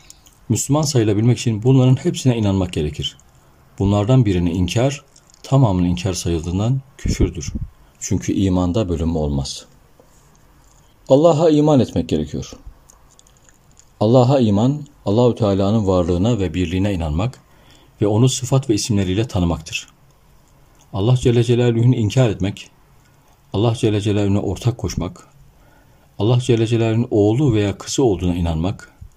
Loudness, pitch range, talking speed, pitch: -18 LUFS, 95-130 Hz, 110 wpm, 115 Hz